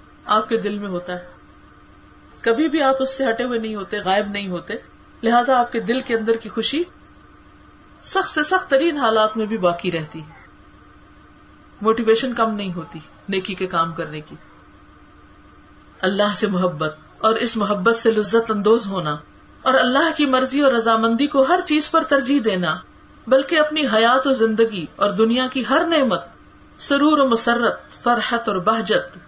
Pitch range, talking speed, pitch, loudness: 165-255 Hz, 170 wpm, 220 Hz, -19 LUFS